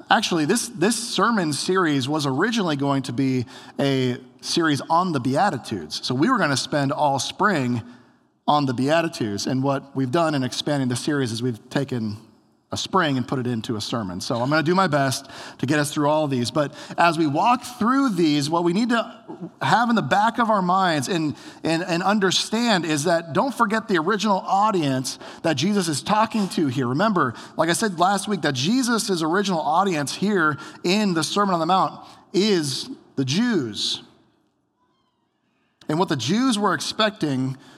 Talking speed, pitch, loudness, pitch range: 190 wpm, 160 Hz, -22 LUFS, 135-195 Hz